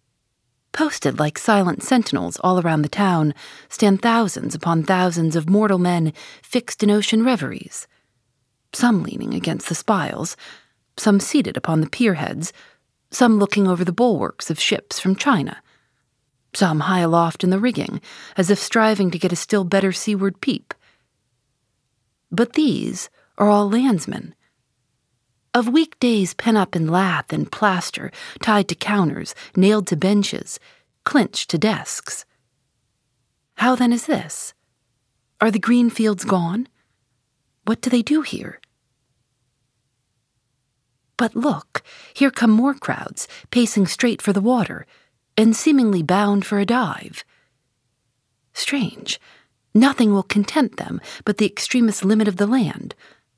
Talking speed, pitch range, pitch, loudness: 135 wpm, 150-230 Hz, 195 Hz, -19 LUFS